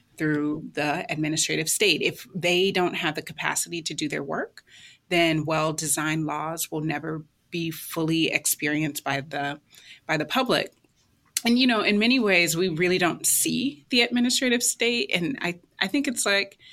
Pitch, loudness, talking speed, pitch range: 170 Hz, -24 LUFS, 170 wpm, 155-205 Hz